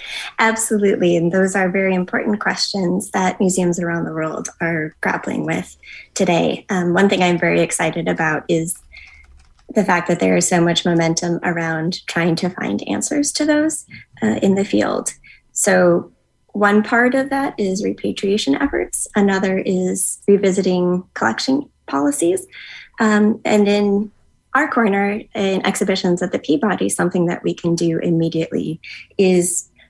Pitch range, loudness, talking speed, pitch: 170-210 Hz, -18 LUFS, 145 wpm, 190 Hz